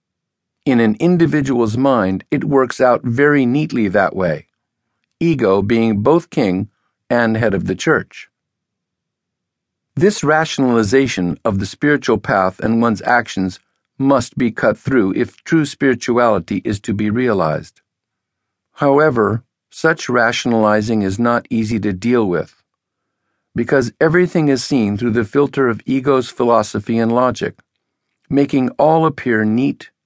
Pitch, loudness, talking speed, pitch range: 120 Hz, -16 LUFS, 130 wpm, 110-140 Hz